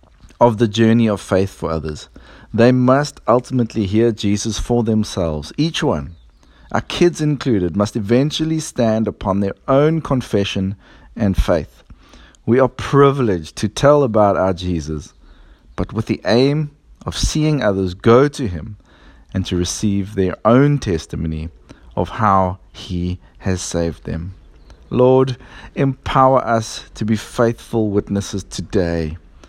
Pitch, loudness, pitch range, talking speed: 105 Hz, -17 LUFS, 90-125 Hz, 135 wpm